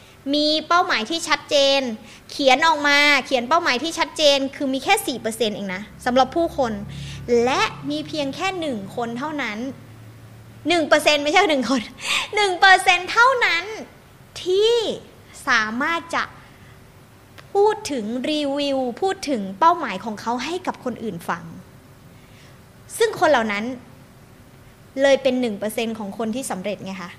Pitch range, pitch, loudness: 225-325 Hz, 275 Hz, -20 LUFS